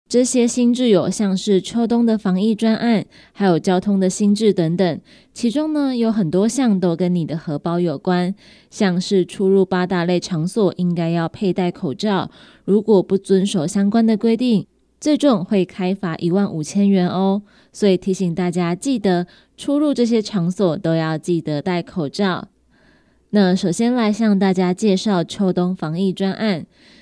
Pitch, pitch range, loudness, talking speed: 190 Hz, 180-220 Hz, -18 LUFS, 245 characters per minute